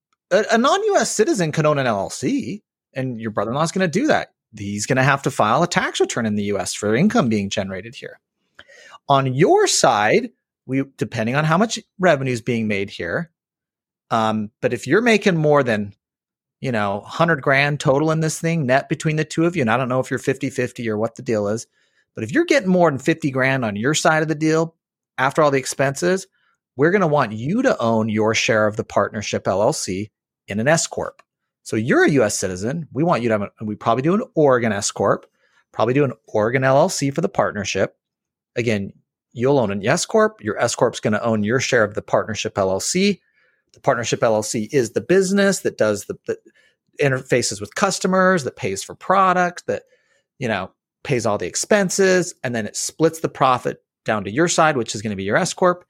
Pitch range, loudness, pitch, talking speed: 115-180 Hz, -19 LUFS, 140 Hz, 220 wpm